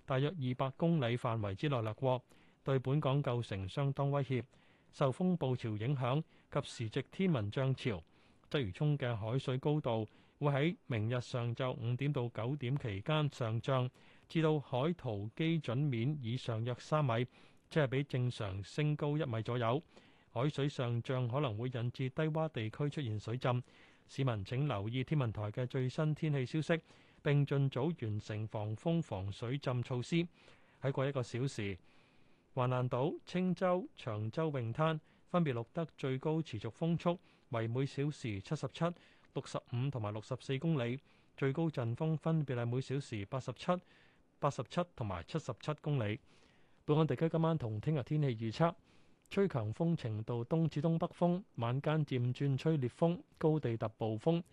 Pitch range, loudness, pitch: 120-155 Hz, -37 LUFS, 135 Hz